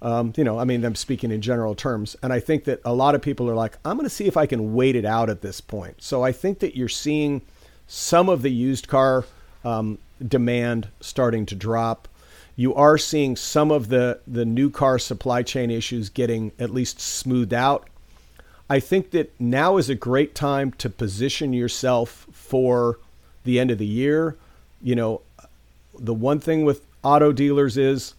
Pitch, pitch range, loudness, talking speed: 125 Hz, 115-140 Hz, -22 LUFS, 195 wpm